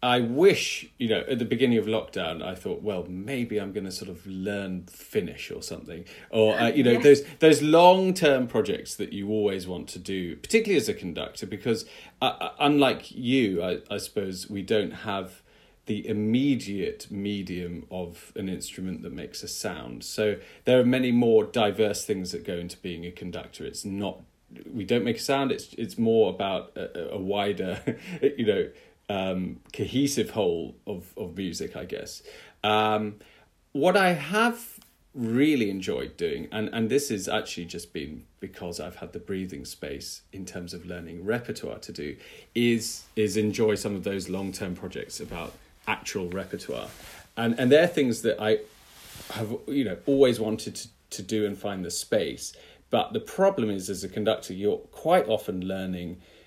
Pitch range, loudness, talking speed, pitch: 95-130 Hz, -27 LUFS, 180 wpm, 105 Hz